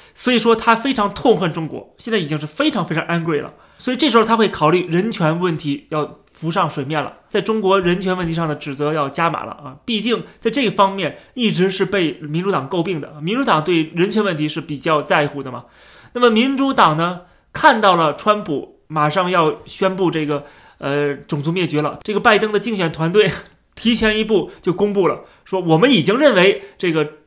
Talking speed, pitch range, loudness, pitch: 310 characters per minute, 155-210 Hz, -17 LUFS, 180 Hz